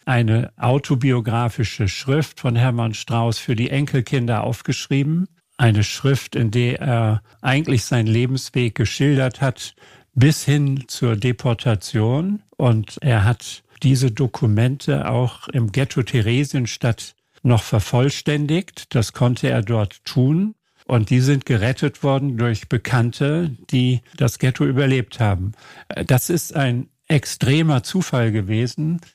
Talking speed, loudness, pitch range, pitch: 120 wpm, -20 LUFS, 115-140 Hz, 125 Hz